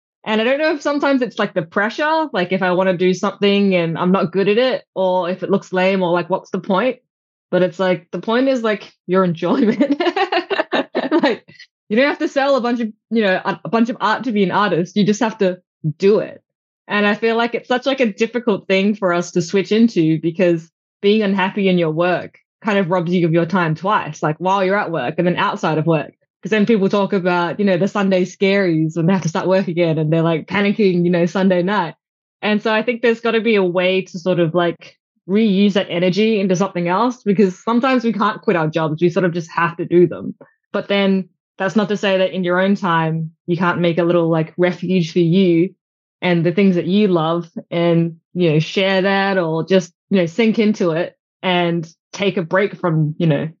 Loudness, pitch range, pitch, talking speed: -17 LUFS, 175-210 Hz, 190 Hz, 235 wpm